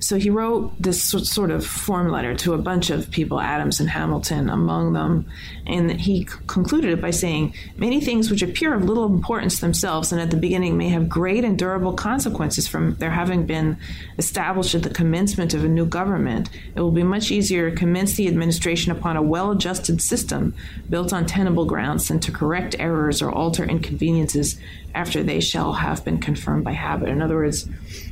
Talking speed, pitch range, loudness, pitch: 195 wpm, 155-185 Hz, -21 LUFS, 170 Hz